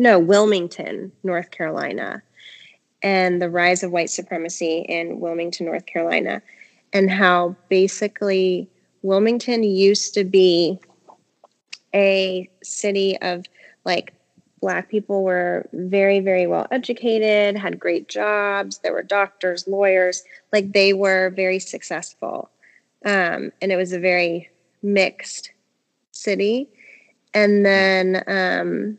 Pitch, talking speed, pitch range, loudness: 190 Hz, 115 wpm, 180-200 Hz, -20 LUFS